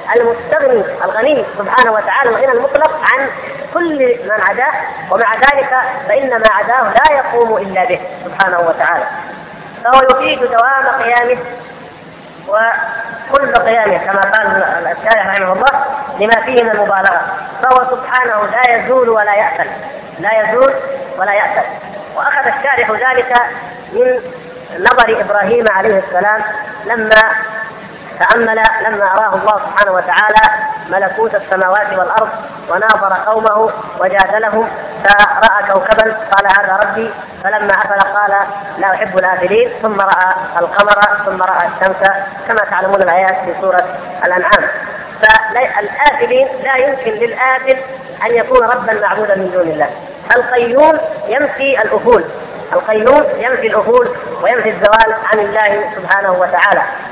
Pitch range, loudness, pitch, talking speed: 200-265 Hz, -11 LUFS, 220 Hz, 120 wpm